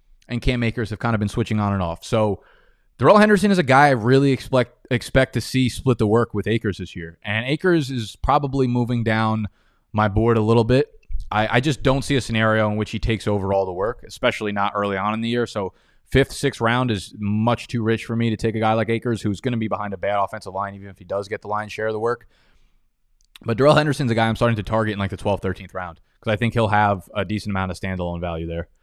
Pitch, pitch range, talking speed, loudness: 110 Hz, 100-120 Hz, 265 wpm, -21 LUFS